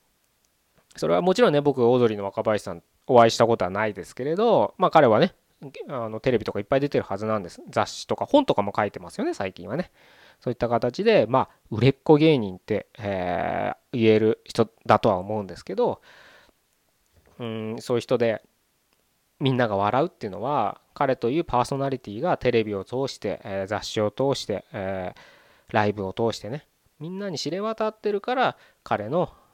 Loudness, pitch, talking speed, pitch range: -24 LUFS, 115 Hz, 370 characters per minute, 105-135 Hz